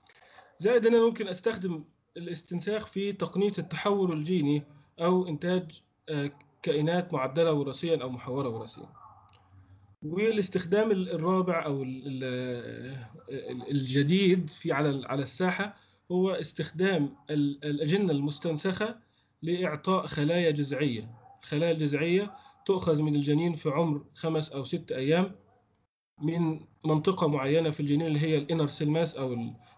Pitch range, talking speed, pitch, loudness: 145-180 Hz, 110 wpm, 160 Hz, -29 LUFS